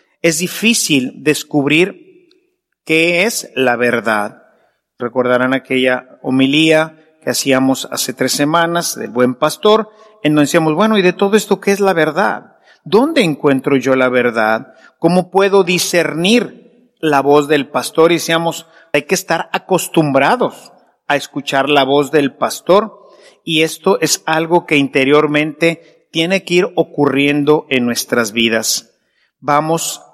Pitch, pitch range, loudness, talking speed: 155 Hz, 135-180 Hz, -14 LUFS, 135 wpm